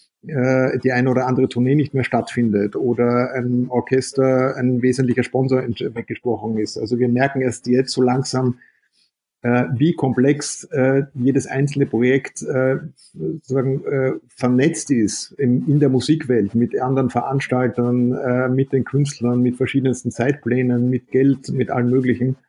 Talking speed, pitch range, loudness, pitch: 130 wpm, 125-135 Hz, -19 LUFS, 130 Hz